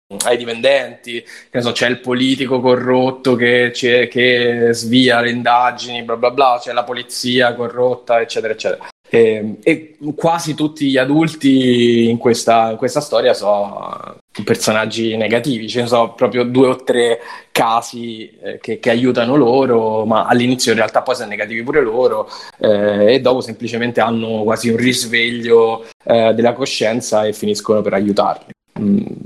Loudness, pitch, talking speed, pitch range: -15 LUFS, 120 Hz, 150 wpm, 115-130 Hz